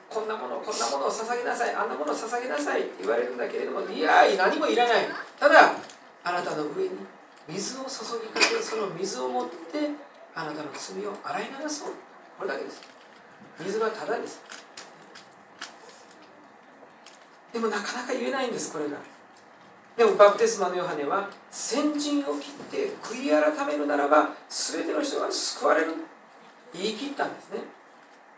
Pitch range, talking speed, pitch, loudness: 205-300 Hz, 320 characters per minute, 235 Hz, -26 LUFS